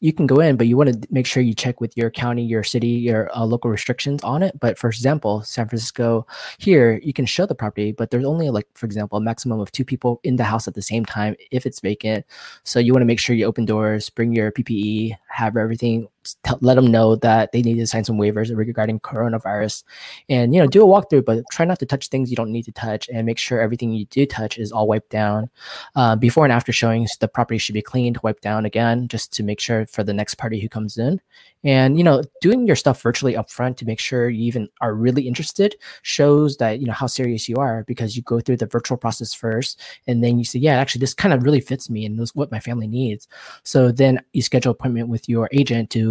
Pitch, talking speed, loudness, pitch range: 115 Hz, 250 wpm, -19 LUFS, 110-130 Hz